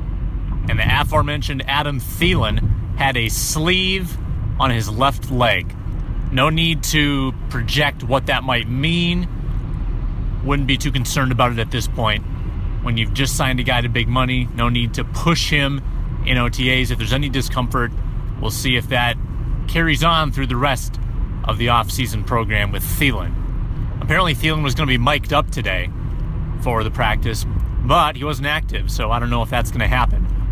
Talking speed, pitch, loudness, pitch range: 175 wpm, 120 Hz, -19 LUFS, 110-135 Hz